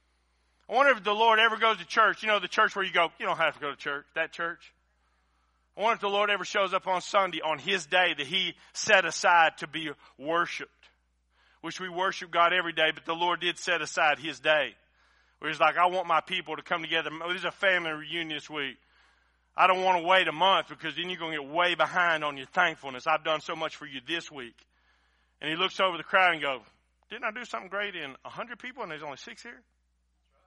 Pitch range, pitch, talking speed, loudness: 150-185 Hz, 165 Hz, 240 wpm, -27 LUFS